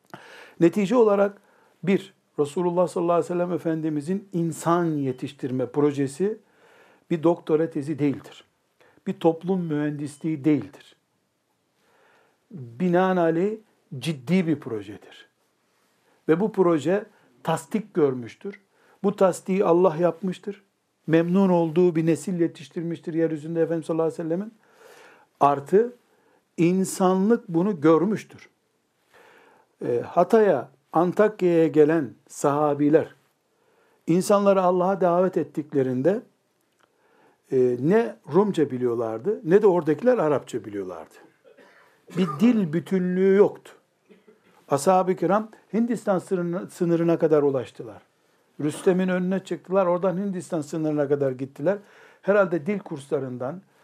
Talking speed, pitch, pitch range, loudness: 95 wpm, 175 Hz, 160-200 Hz, -23 LUFS